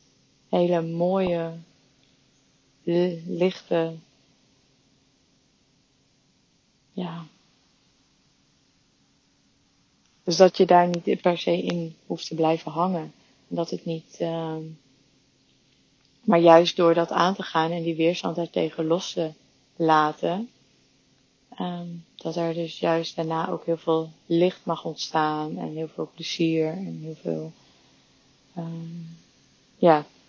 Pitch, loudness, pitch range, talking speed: 165 Hz, -24 LUFS, 160-170 Hz, 115 wpm